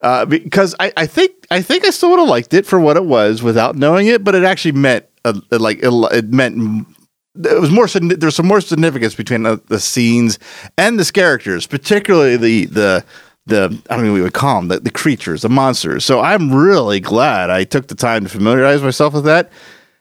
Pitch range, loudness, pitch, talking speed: 115-180 Hz, -13 LUFS, 135 Hz, 220 wpm